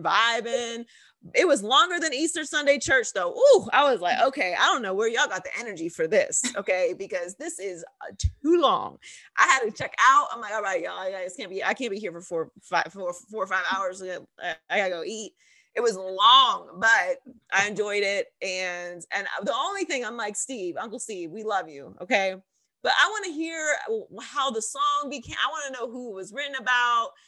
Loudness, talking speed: -25 LUFS, 220 wpm